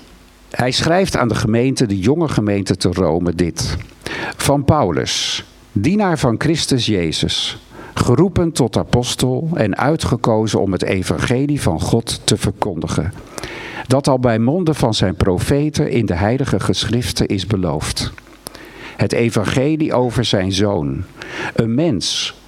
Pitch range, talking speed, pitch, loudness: 100-135 Hz, 130 wpm, 120 Hz, -17 LUFS